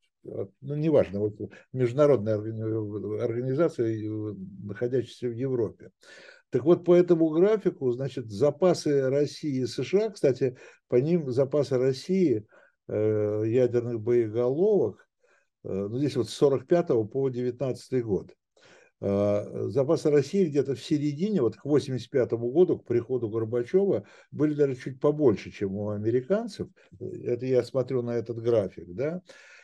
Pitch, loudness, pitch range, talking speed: 130 Hz, -27 LUFS, 115-155 Hz, 120 wpm